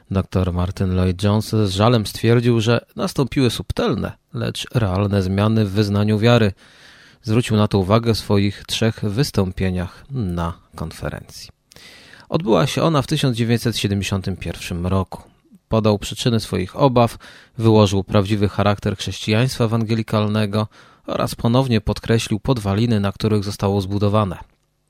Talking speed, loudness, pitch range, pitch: 115 wpm, -19 LUFS, 100-115 Hz, 105 Hz